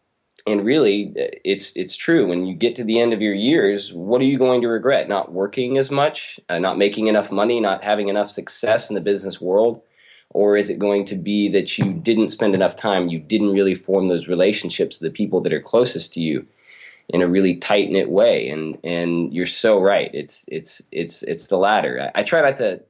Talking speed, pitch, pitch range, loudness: 225 wpm, 100 Hz, 95-115 Hz, -19 LUFS